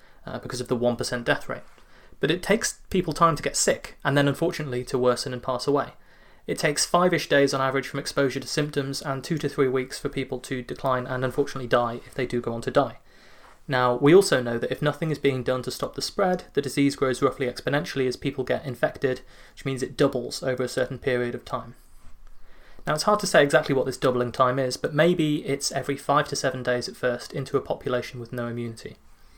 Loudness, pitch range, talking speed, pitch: -25 LUFS, 125-145 Hz, 230 wpm, 135 Hz